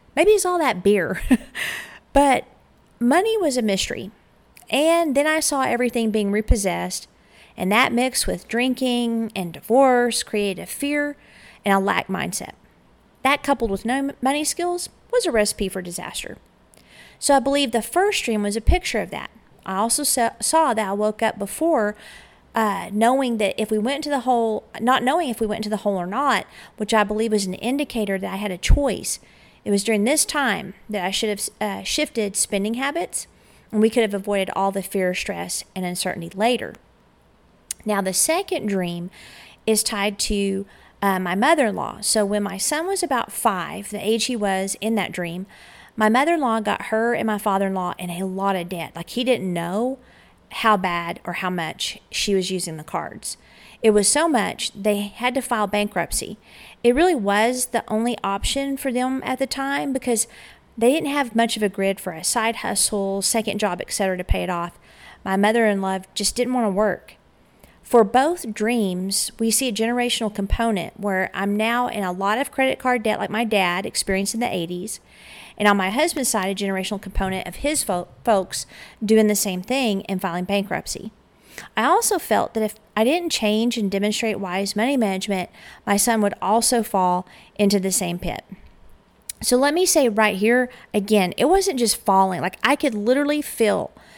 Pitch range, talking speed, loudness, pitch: 195-250 Hz, 190 wpm, -21 LUFS, 215 Hz